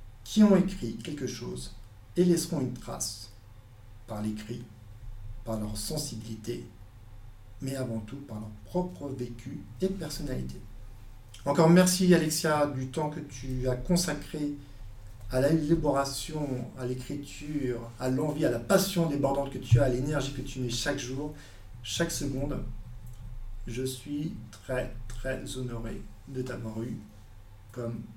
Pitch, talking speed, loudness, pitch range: 125 Hz, 135 wpm, -30 LUFS, 110-145 Hz